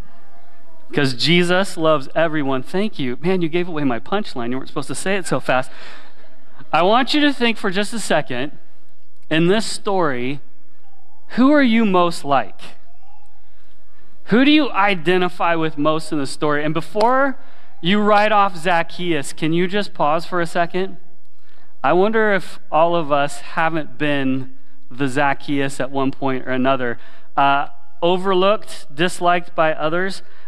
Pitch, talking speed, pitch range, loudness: 170 Hz, 155 wpm, 145-200 Hz, -19 LUFS